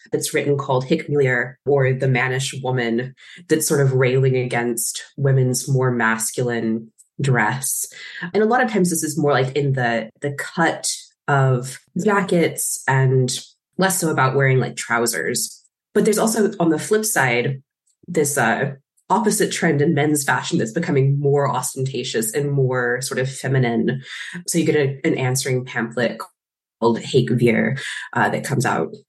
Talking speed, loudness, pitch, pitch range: 155 wpm, -20 LUFS, 135 Hz, 125-155 Hz